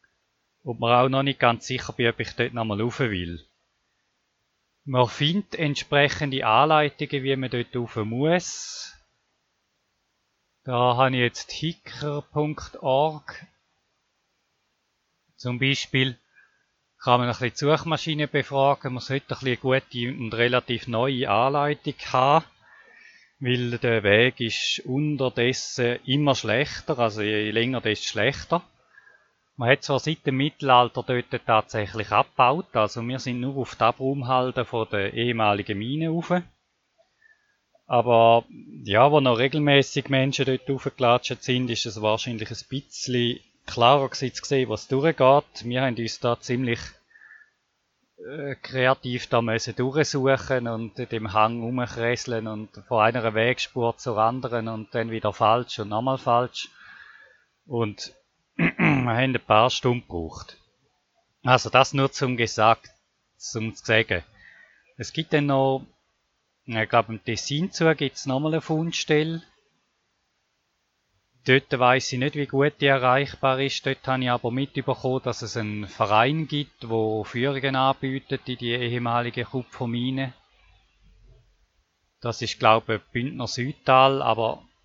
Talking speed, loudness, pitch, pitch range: 130 wpm, -24 LUFS, 125 Hz, 115-135 Hz